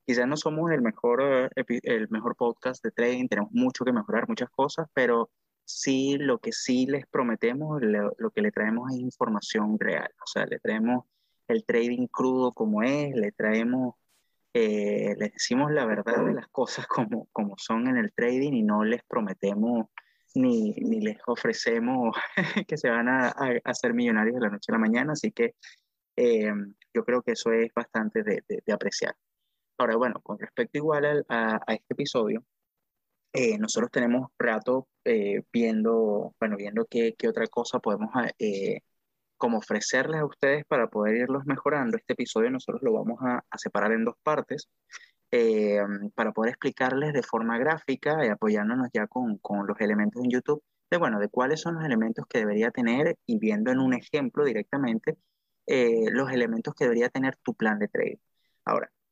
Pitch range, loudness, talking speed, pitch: 115-190 Hz, -27 LUFS, 180 wpm, 130 Hz